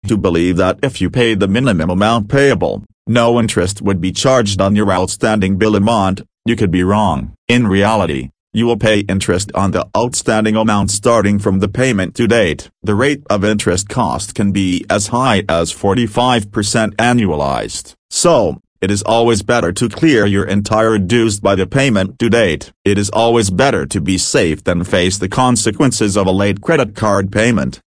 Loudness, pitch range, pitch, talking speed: -14 LUFS, 95-115 Hz, 105 Hz, 180 wpm